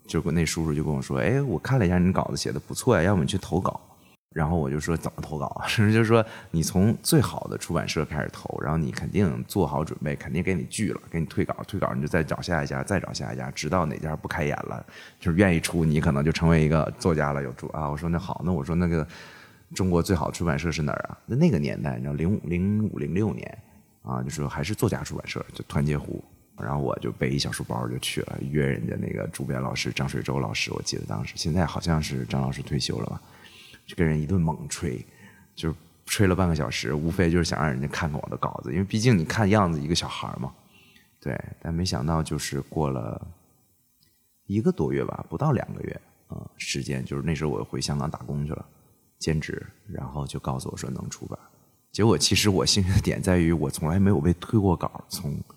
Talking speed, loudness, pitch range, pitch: 340 characters per minute, -26 LUFS, 75-90 Hz, 80 Hz